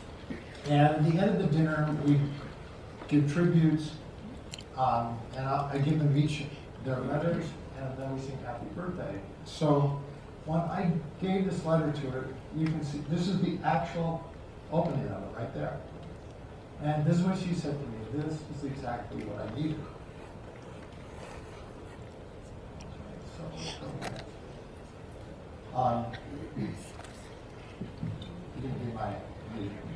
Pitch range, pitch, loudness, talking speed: 120-155 Hz, 145 Hz, -32 LUFS, 125 wpm